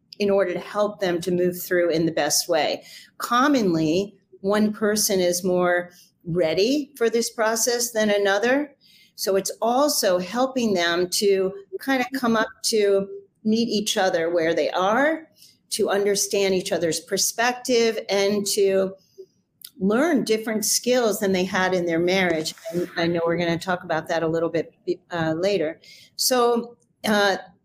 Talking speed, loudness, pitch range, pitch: 155 wpm, -22 LUFS, 180-225 Hz, 195 Hz